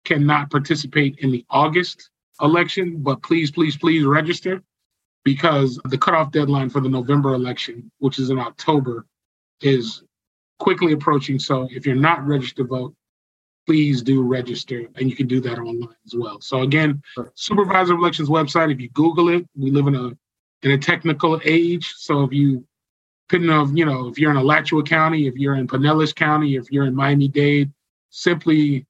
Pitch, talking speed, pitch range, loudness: 145 Hz, 175 wpm, 130-160 Hz, -19 LUFS